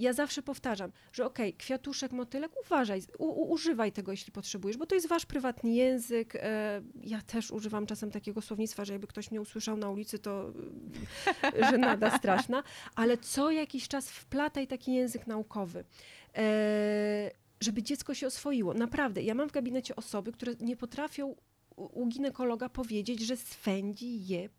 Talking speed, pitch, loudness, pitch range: 165 wpm, 235 Hz, -34 LUFS, 210-270 Hz